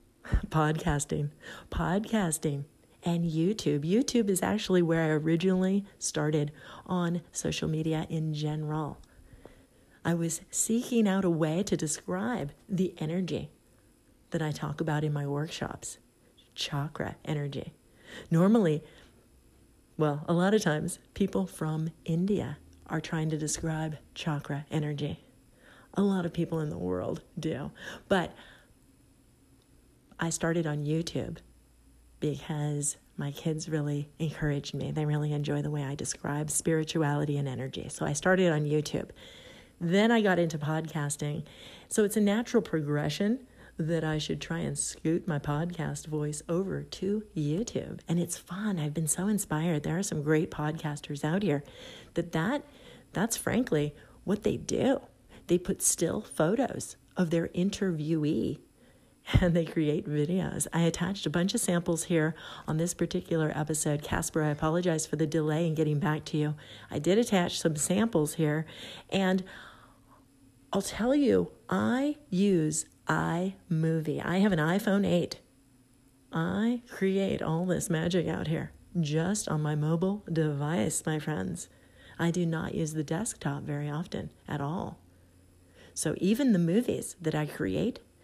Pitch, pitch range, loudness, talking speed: 160 Hz, 150-180 Hz, -30 LUFS, 140 wpm